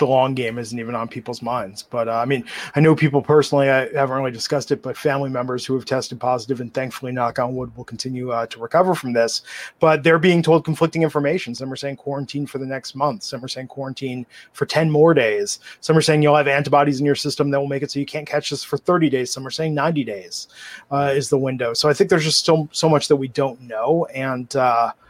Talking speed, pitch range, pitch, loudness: 255 wpm, 125-150 Hz, 140 Hz, -20 LUFS